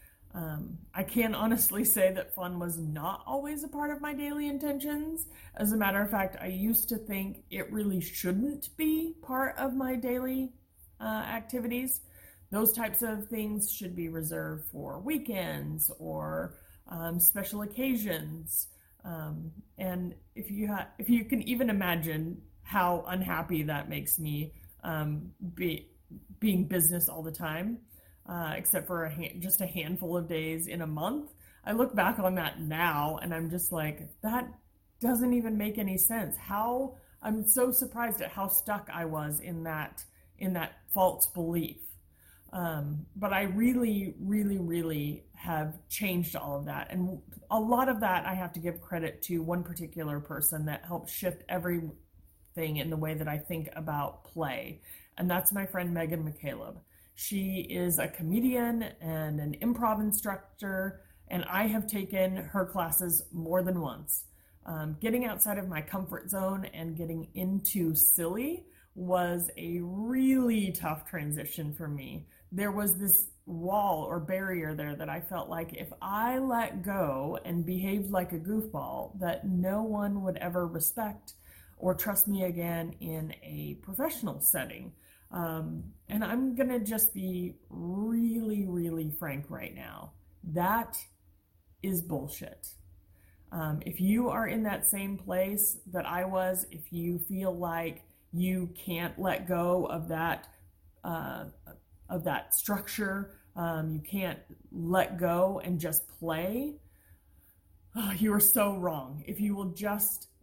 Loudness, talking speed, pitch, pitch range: -31 LUFS, 155 wpm, 180 Hz, 160-210 Hz